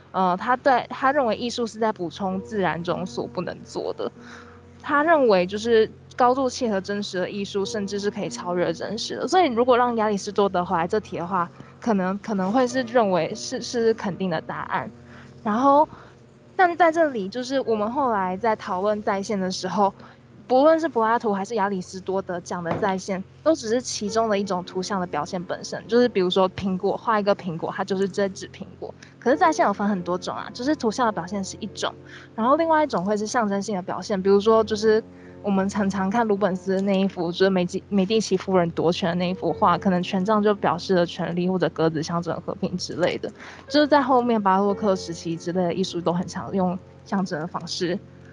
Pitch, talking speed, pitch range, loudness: 200 Hz, 320 characters per minute, 180-230 Hz, -23 LUFS